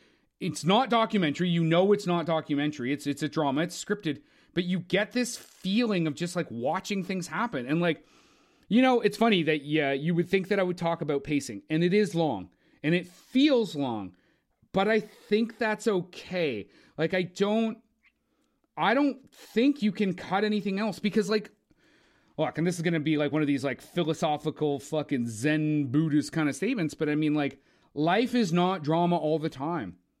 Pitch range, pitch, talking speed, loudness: 155-210 Hz, 175 Hz, 195 wpm, -28 LUFS